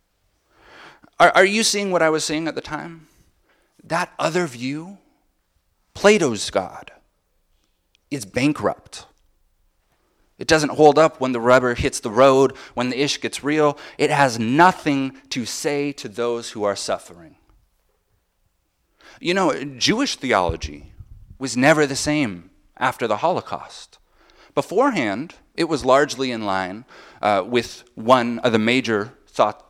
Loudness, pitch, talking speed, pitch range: -20 LUFS, 130 Hz, 135 wpm, 100-150 Hz